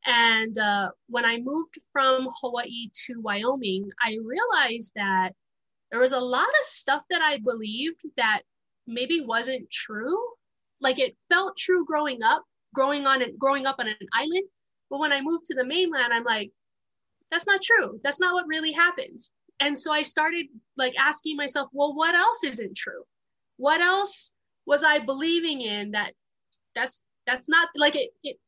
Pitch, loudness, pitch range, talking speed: 280 Hz, -25 LUFS, 240-330 Hz, 170 wpm